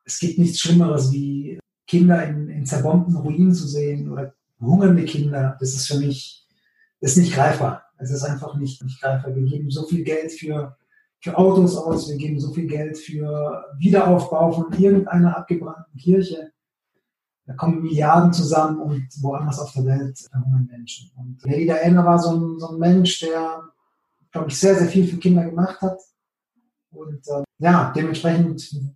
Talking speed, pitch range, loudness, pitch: 175 wpm, 140-175 Hz, -20 LUFS, 155 Hz